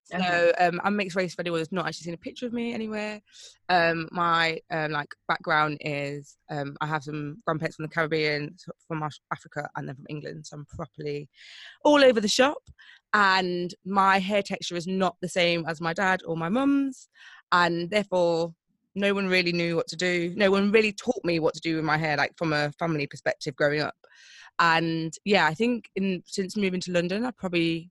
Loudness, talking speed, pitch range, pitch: -26 LUFS, 205 wpm, 160-195 Hz, 170 Hz